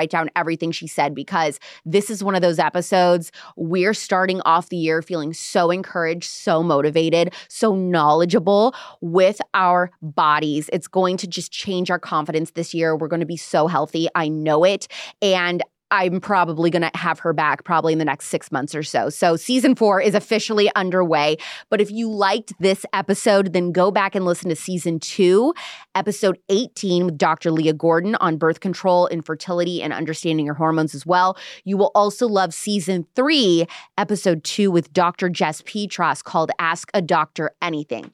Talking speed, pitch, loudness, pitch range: 180 wpm, 175 Hz, -20 LUFS, 160-195 Hz